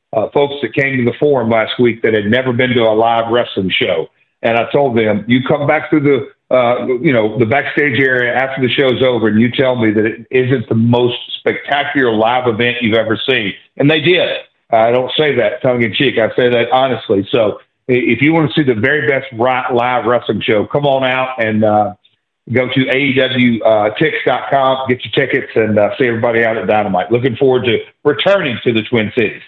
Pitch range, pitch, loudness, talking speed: 115-135 Hz, 125 Hz, -13 LUFS, 210 wpm